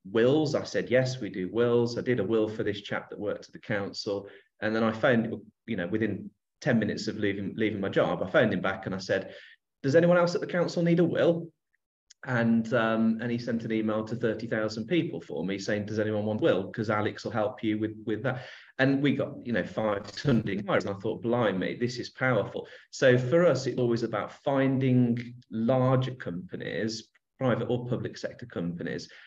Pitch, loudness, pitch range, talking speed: 115 Hz, -28 LUFS, 110-125 Hz, 210 wpm